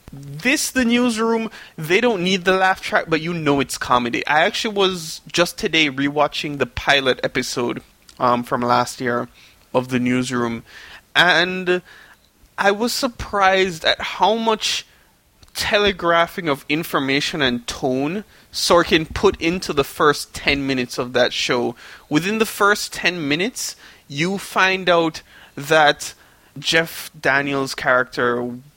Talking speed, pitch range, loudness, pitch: 135 wpm, 135-190 Hz, -19 LUFS, 160 Hz